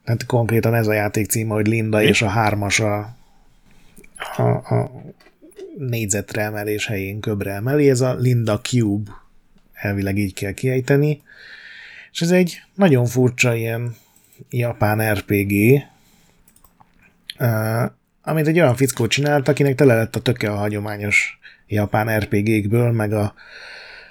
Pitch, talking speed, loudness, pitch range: 110 Hz, 125 wpm, -19 LUFS, 105-130 Hz